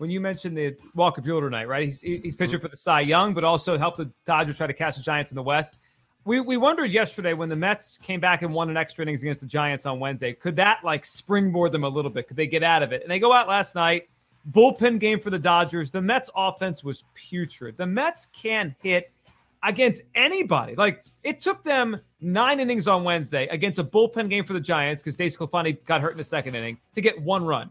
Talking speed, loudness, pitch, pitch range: 240 wpm, -24 LUFS, 170 Hz, 150-200 Hz